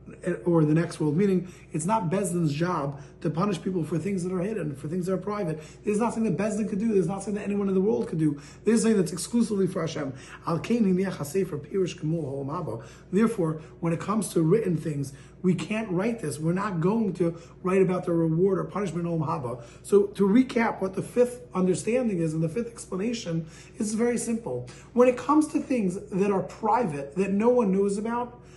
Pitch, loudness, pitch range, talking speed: 185 Hz, -27 LUFS, 165-210 Hz, 195 wpm